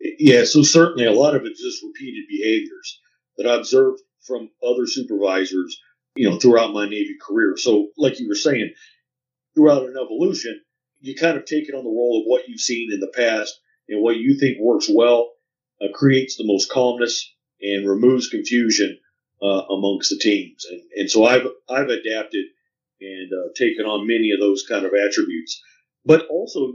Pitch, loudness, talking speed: 140 Hz, -19 LUFS, 180 wpm